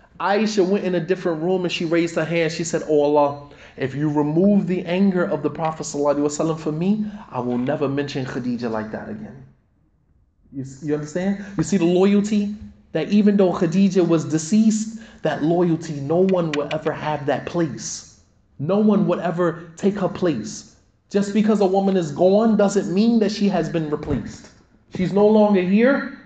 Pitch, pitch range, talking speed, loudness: 175 Hz, 150-195 Hz, 180 wpm, -20 LUFS